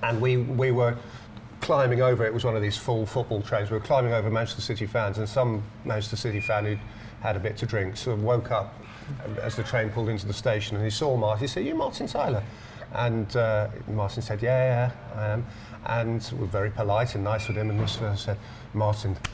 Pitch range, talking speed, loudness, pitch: 105-120 Hz, 230 wpm, -27 LUFS, 110 Hz